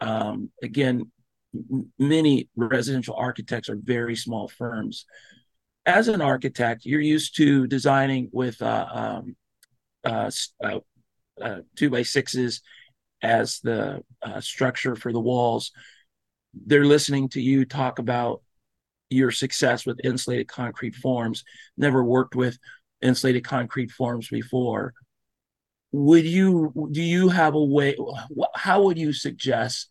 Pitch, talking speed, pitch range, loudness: 130 Hz, 125 wpm, 120-140 Hz, -23 LUFS